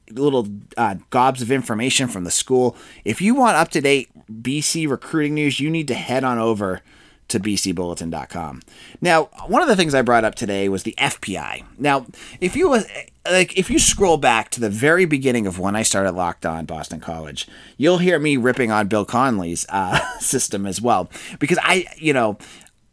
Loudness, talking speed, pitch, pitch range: -19 LUFS, 190 wpm, 120 Hz, 100-145 Hz